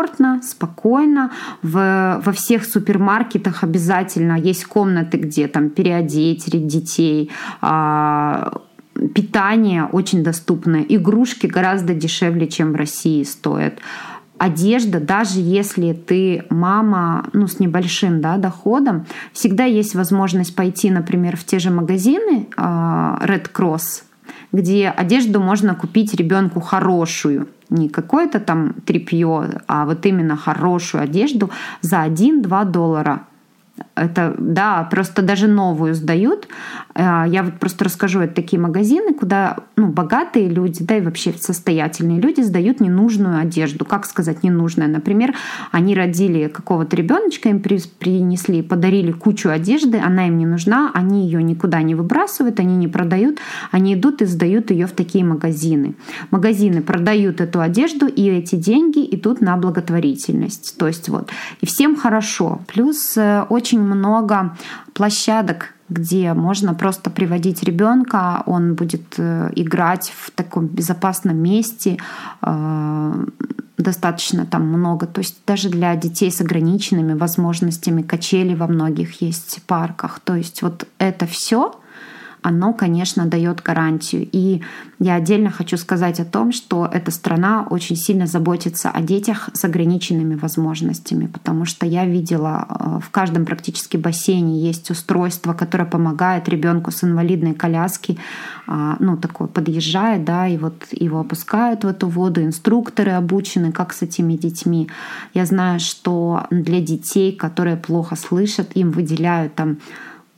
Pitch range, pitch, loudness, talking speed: 170-205 Hz, 180 Hz, -17 LUFS, 130 wpm